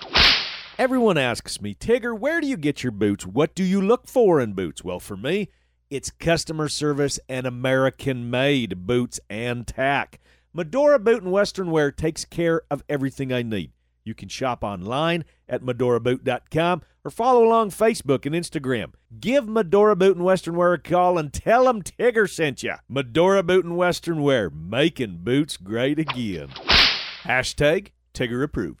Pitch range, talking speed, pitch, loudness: 125-185 Hz, 160 wpm, 150 Hz, -22 LUFS